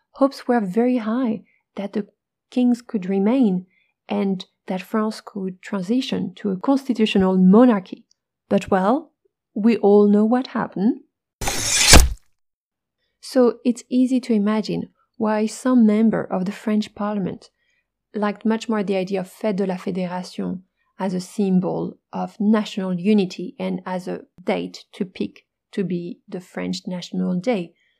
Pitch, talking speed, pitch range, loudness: 210 Hz, 140 wpm, 190-240 Hz, -21 LUFS